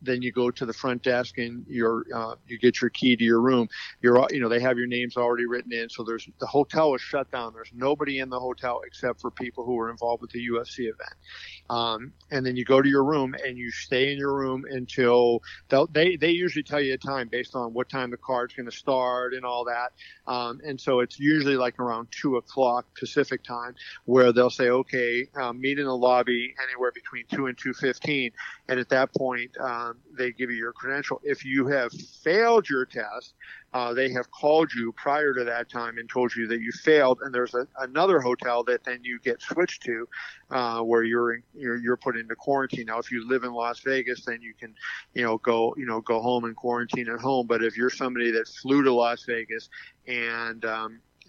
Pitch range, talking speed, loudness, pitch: 120-130 Hz, 225 wpm, -26 LUFS, 125 Hz